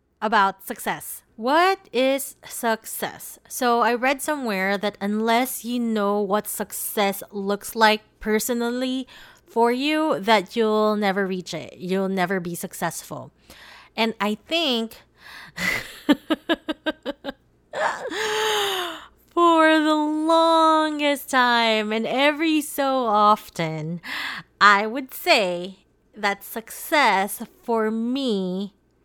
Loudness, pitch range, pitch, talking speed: -22 LUFS, 205-295 Hz, 230 Hz, 95 wpm